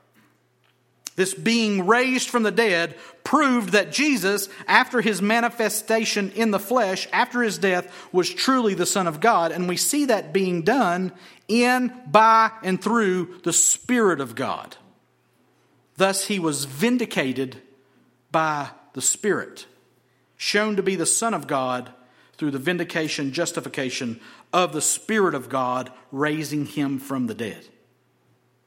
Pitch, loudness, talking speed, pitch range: 185 Hz, -22 LUFS, 140 wpm, 145-220 Hz